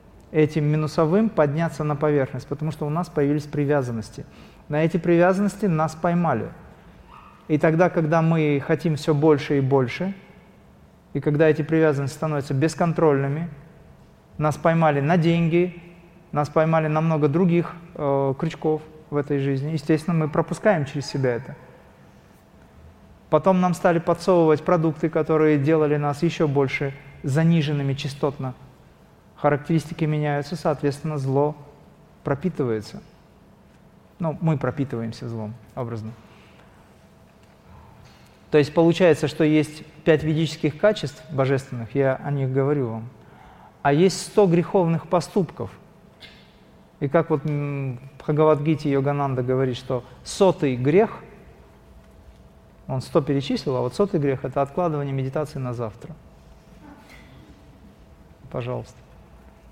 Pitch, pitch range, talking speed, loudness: 150 Hz, 135-165 Hz, 115 wpm, -22 LUFS